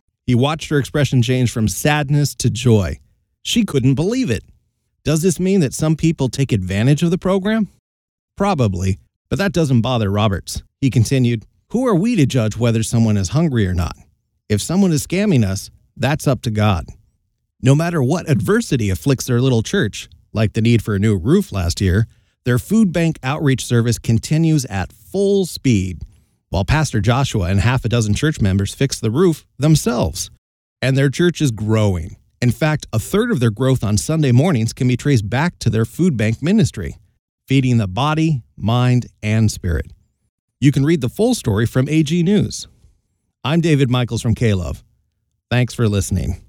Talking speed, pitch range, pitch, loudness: 180 wpm, 105-150 Hz, 120 Hz, -17 LUFS